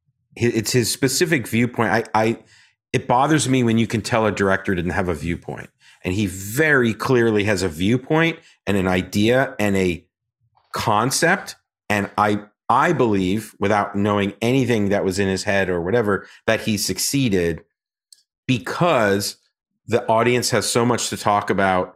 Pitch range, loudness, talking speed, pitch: 100-125 Hz, -20 LUFS, 160 wpm, 110 Hz